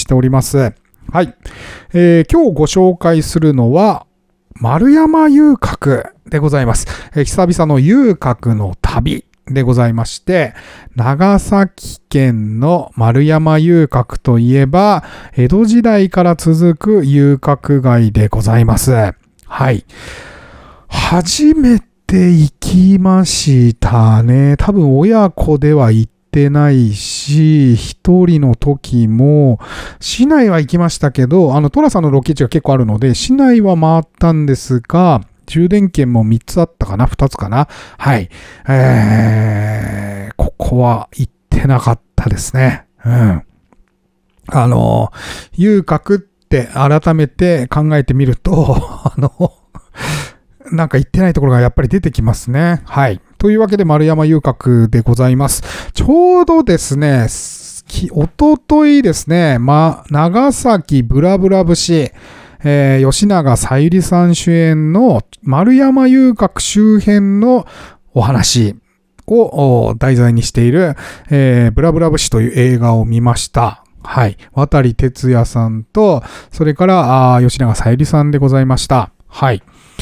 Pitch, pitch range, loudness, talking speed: 145 Hz, 120-175 Hz, -11 LUFS, 245 characters per minute